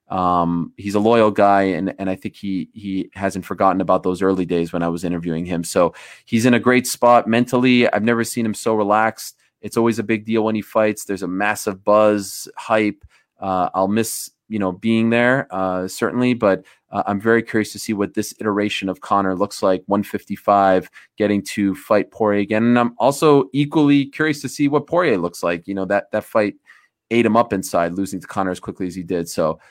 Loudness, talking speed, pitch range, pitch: -19 LUFS, 215 wpm, 95-115 Hz, 105 Hz